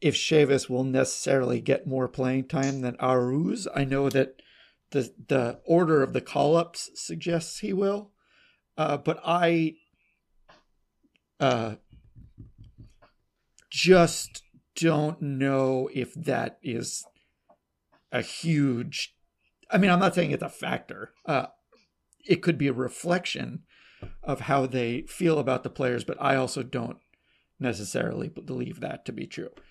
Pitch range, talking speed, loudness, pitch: 125-165 Hz, 130 wpm, -27 LUFS, 135 Hz